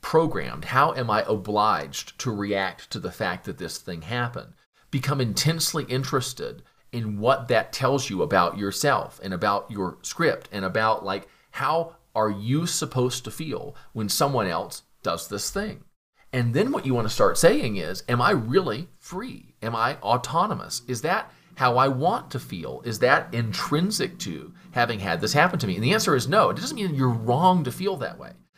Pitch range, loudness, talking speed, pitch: 110-155 Hz, -25 LUFS, 190 wpm, 130 Hz